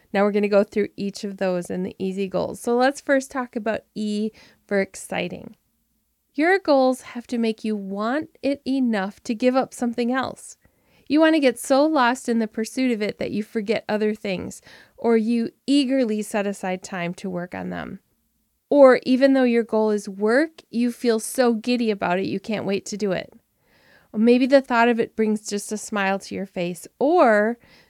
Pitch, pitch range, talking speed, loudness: 225 Hz, 205-255 Hz, 200 wpm, -22 LUFS